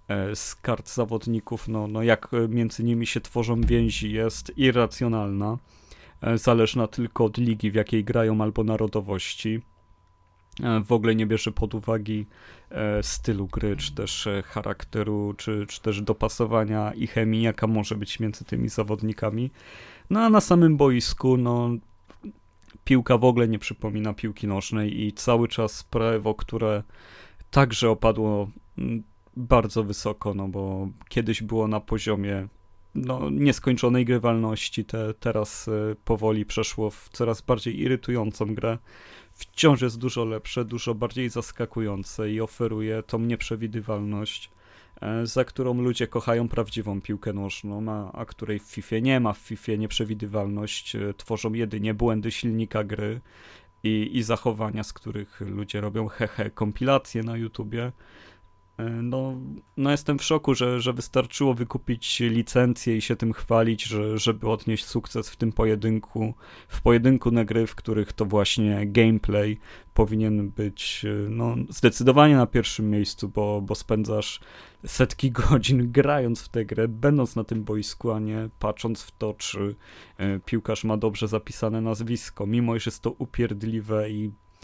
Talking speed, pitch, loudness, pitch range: 140 wpm, 110 Hz, -25 LUFS, 105-120 Hz